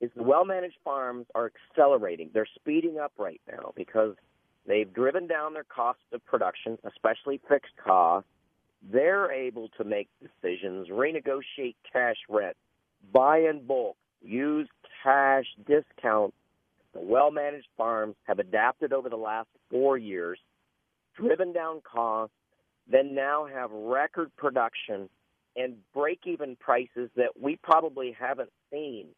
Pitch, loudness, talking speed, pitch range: 130 Hz, -28 LUFS, 135 wpm, 115-150 Hz